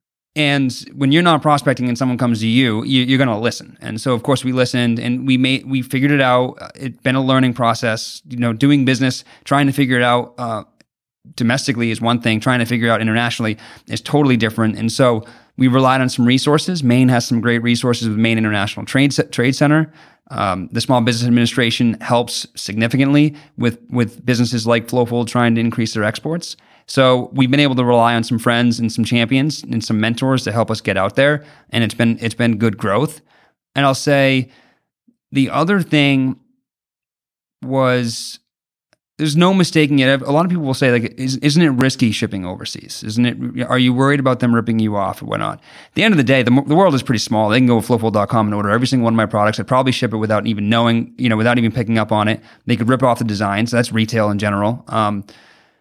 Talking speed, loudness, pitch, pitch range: 225 wpm, -16 LUFS, 120 Hz, 115-135 Hz